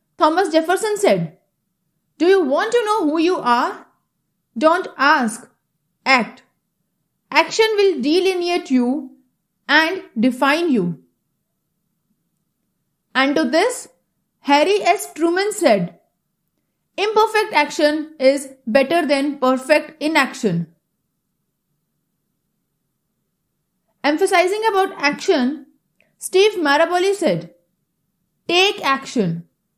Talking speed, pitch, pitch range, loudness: 85 wpm, 285 Hz, 215-350 Hz, -17 LUFS